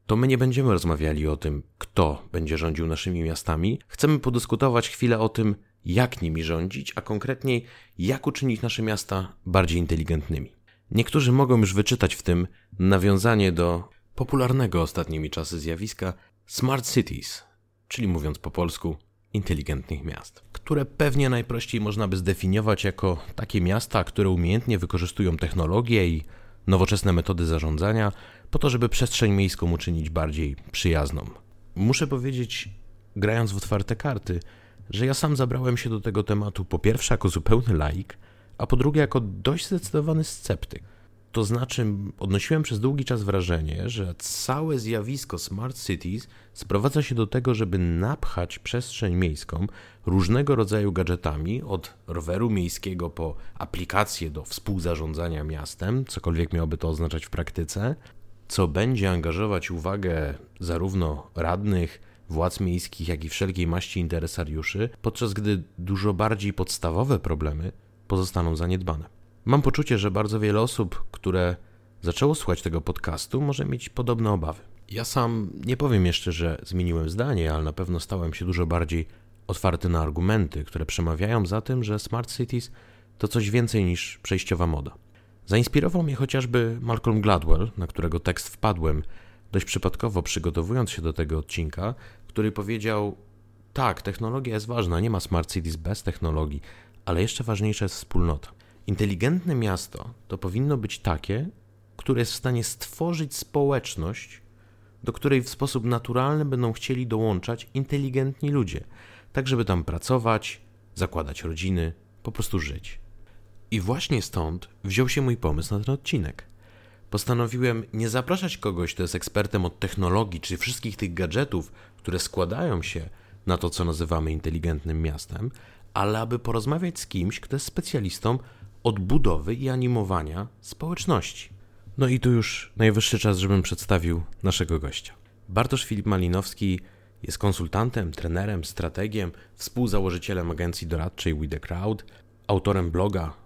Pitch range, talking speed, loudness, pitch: 90-115 Hz, 140 wpm, -26 LUFS, 100 Hz